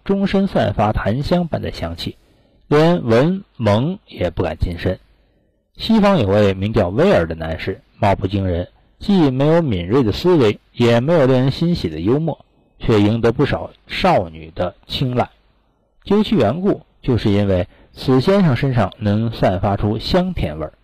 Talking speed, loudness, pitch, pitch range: 235 characters per minute, -17 LUFS, 115 Hz, 100-160 Hz